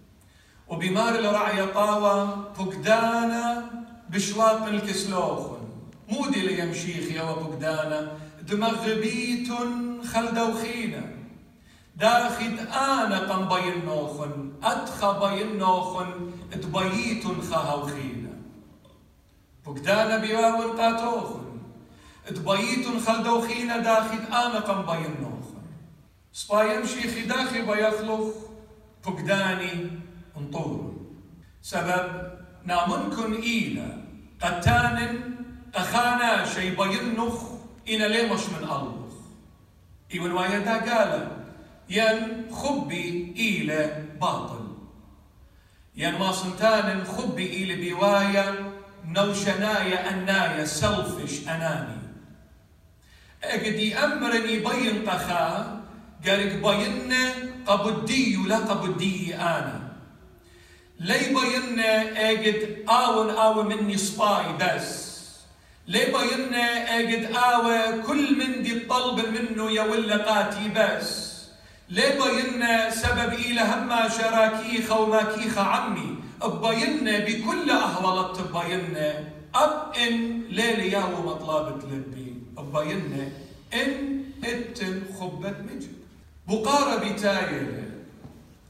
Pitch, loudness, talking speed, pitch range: 210 Hz, -25 LUFS, 80 wpm, 175-230 Hz